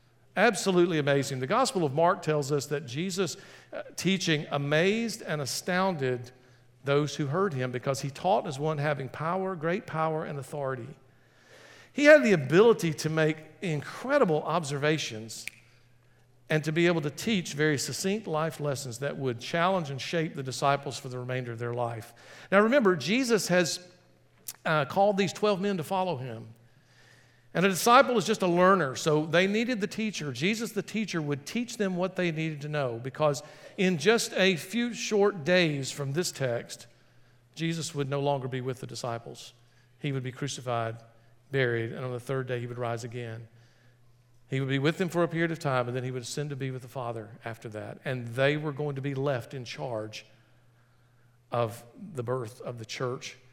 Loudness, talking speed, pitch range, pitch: -28 LUFS, 185 wpm, 125-175 Hz, 145 Hz